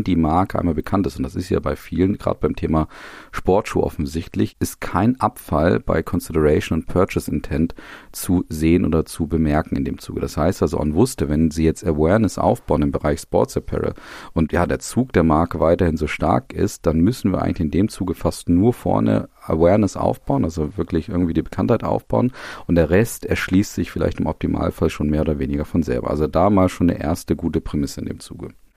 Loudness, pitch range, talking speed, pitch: -20 LUFS, 80-95 Hz, 205 wpm, 85 Hz